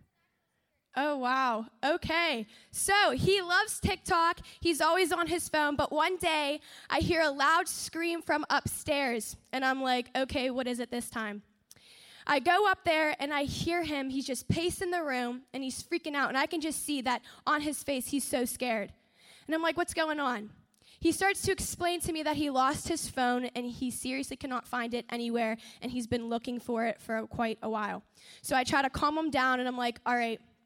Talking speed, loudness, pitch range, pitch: 205 wpm, -31 LUFS, 245-320 Hz, 275 Hz